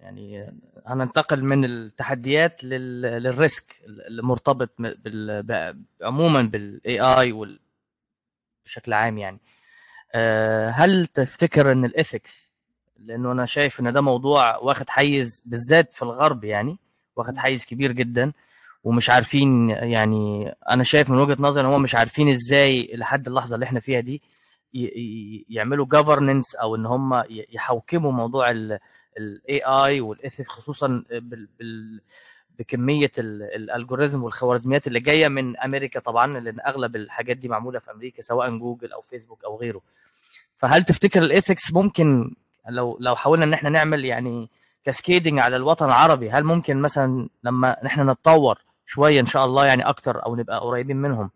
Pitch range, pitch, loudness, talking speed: 115-140 Hz, 125 Hz, -20 LUFS, 145 wpm